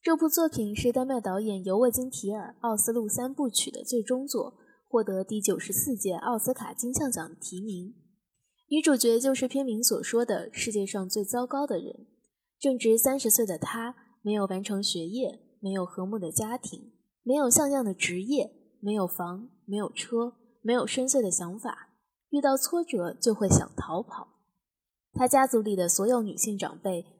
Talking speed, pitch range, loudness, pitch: 260 characters per minute, 200-255 Hz, -28 LUFS, 230 Hz